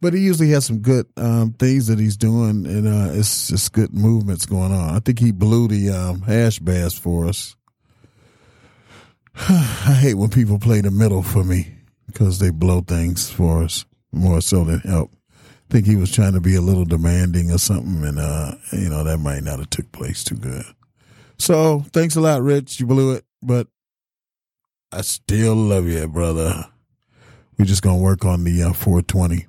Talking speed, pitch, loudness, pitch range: 195 wpm, 105 Hz, -18 LUFS, 90-120 Hz